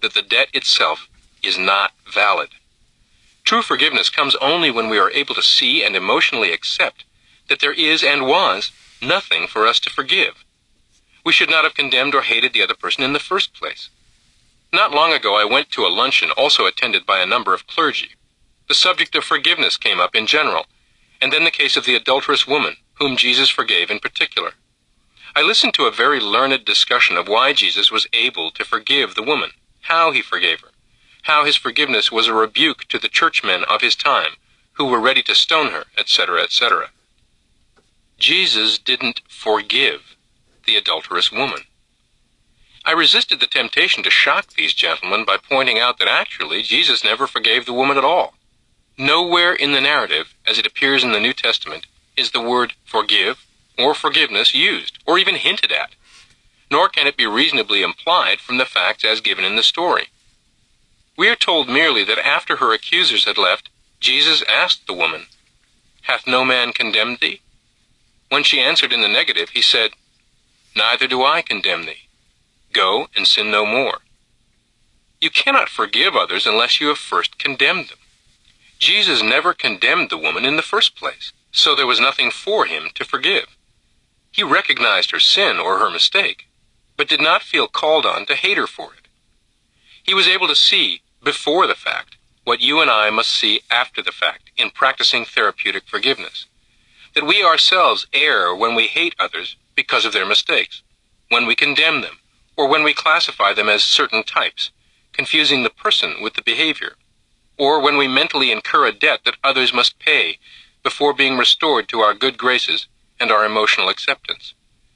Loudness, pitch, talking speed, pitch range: -15 LUFS, 130 Hz, 175 wpm, 115-145 Hz